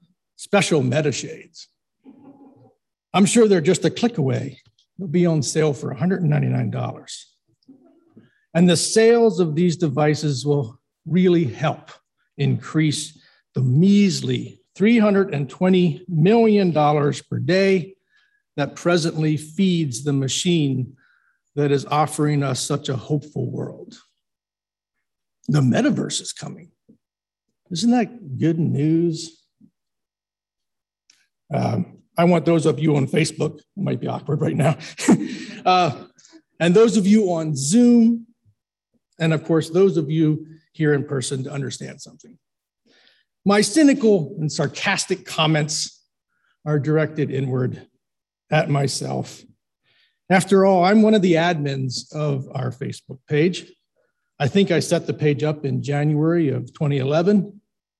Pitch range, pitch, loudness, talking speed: 145-185 Hz, 160 Hz, -20 LUFS, 120 wpm